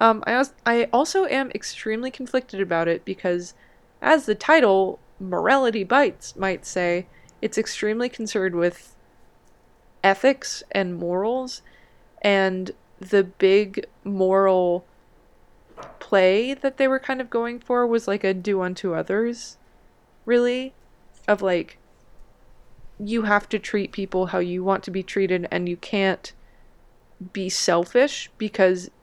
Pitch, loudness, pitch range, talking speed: 200 Hz, -22 LUFS, 190-240 Hz, 125 wpm